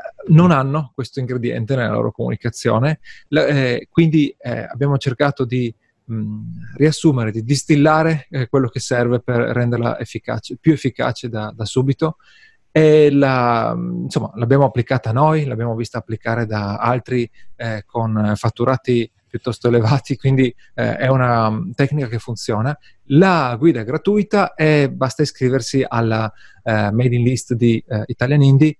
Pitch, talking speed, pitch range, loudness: 125 Hz, 145 wpm, 115-145 Hz, -18 LUFS